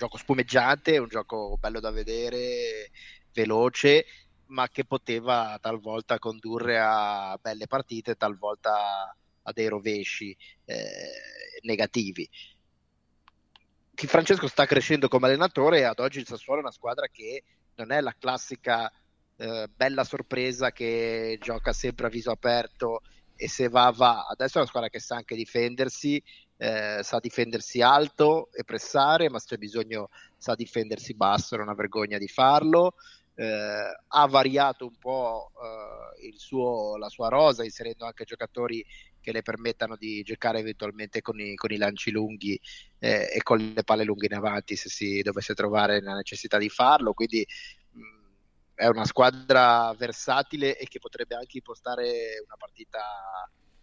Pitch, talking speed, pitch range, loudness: 115 Hz, 150 wpm, 105-130 Hz, -26 LUFS